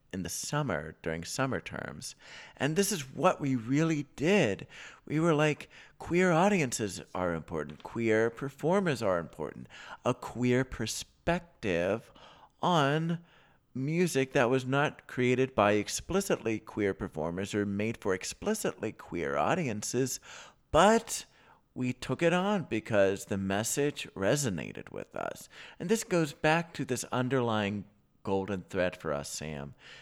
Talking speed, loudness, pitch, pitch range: 130 wpm, -31 LUFS, 125 Hz, 100-155 Hz